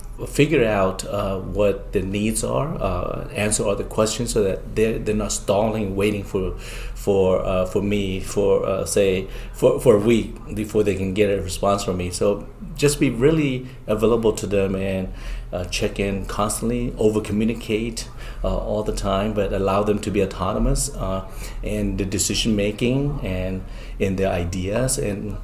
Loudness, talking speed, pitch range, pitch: -22 LUFS, 170 wpm, 95-110 Hz, 105 Hz